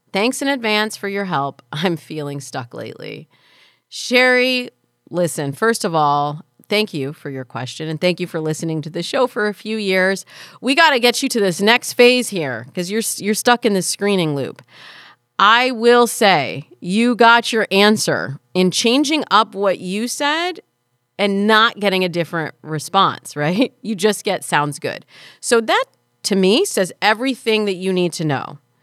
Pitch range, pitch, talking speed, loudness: 160-230 Hz, 195 Hz, 180 wpm, -17 LUFS